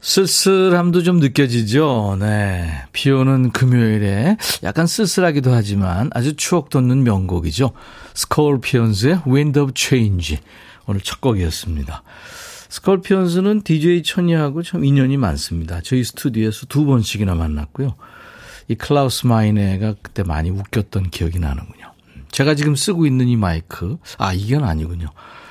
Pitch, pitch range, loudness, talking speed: 125 Hz, 100-150 Hz, -17 LUFS, 325 characters per minute